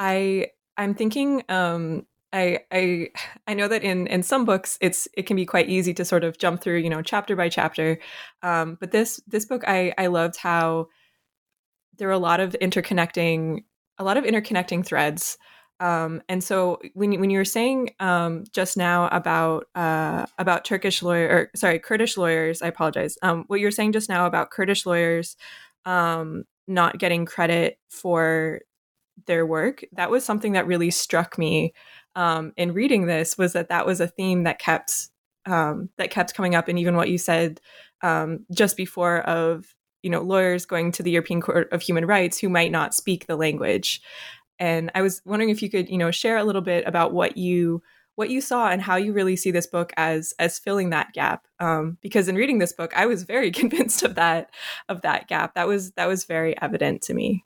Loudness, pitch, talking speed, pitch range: -23 LUFS, 180 Hz, 200 wpm, 170-195 Hz